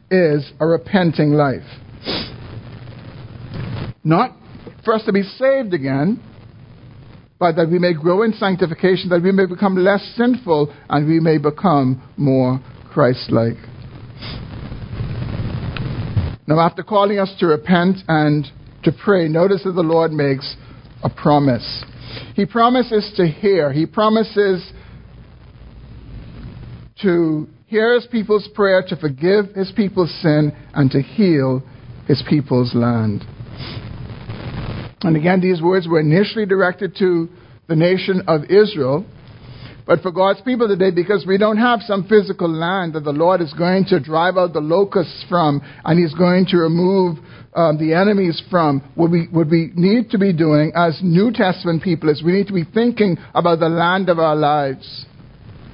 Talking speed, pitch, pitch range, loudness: 145 wpm, 165 Hz, 135-190 Hz, -17 LUFS